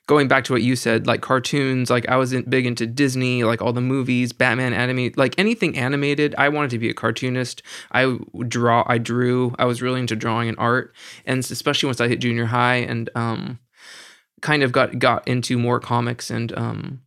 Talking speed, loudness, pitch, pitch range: 205 wpm, -20 LUFS, 125 Hz, 120-130 Hz